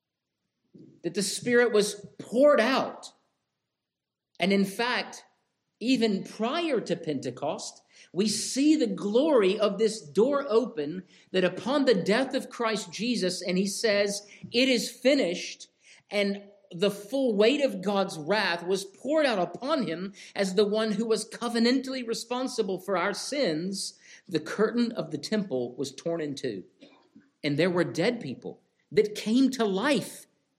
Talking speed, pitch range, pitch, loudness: 145 wpm, 185-245 Hz, 210 Hz, -27 LUFS